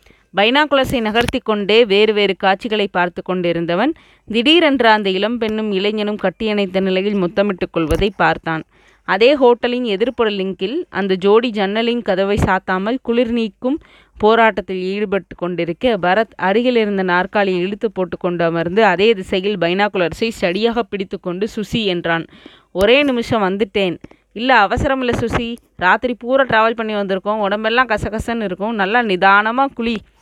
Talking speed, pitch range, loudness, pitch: 125 wpm, 190-230 Hz, -16 LUFS, 210 Hz